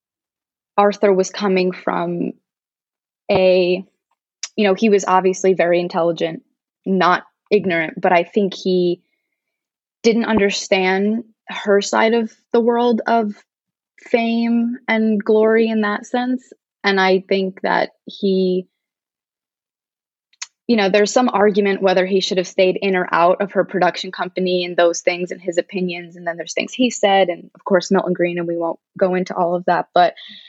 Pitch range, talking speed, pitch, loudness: 180-220 Hz, 155 wpm, 190 Hz, -18 LUFS